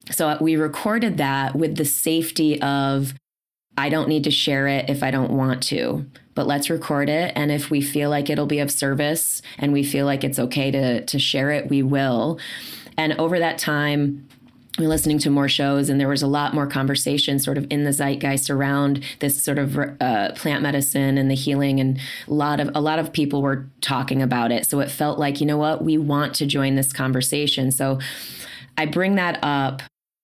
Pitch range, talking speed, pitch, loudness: 135-150 Hz, 210 wpm, 140 Hz, -21 LUFS